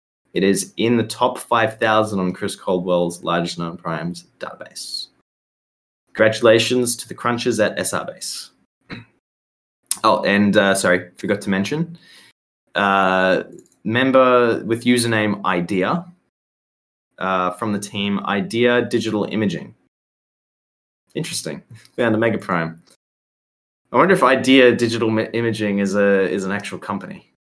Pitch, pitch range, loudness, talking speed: 105 Hz, 90-120 Hz, -19 LUFS, 120 wpm